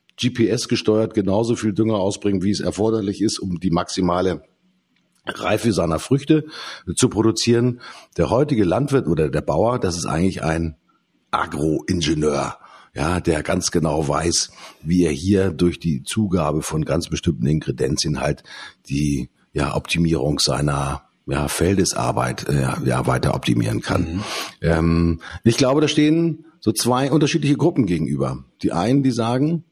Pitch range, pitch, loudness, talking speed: 80-120 Hz, 95 Hz, -20 LUFS, 140 wpm